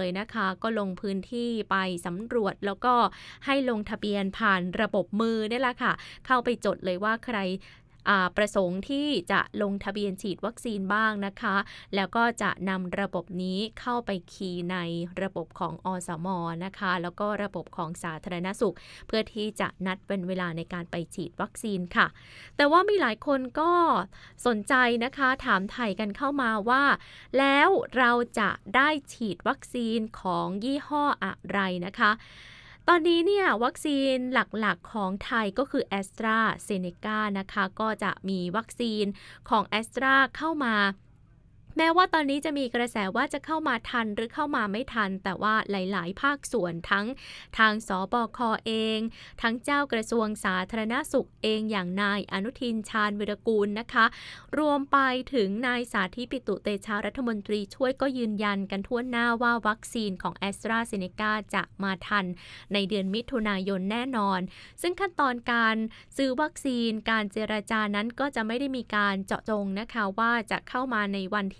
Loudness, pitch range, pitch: -28 LUFS, 195-245 Hz, 215 Hz